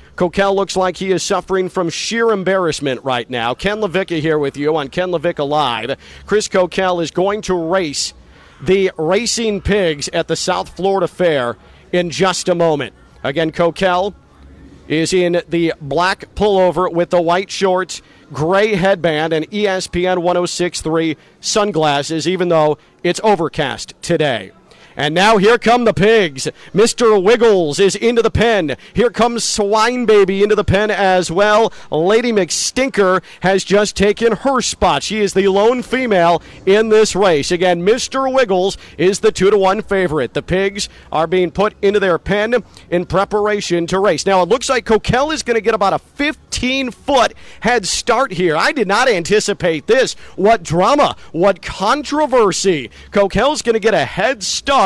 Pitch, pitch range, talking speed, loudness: 190 Hz, 170-210 Hz, 165 wpm, -15 LUFS